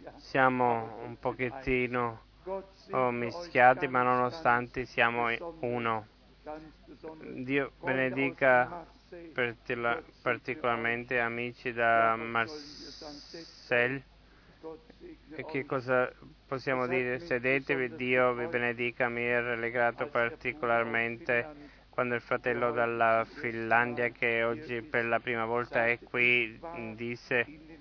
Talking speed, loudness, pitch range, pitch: 90 wpm, -30 LUFS, 120-135 Hz, 125 Hz